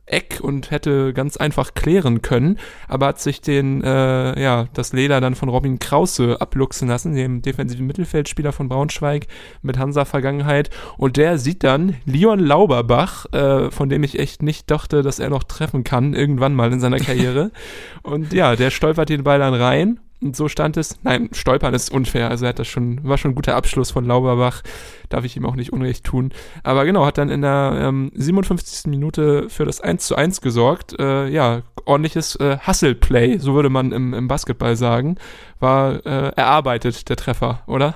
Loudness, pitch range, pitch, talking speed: -18 LUFS, 125-150 Hz, 135 Hz, 190 wpm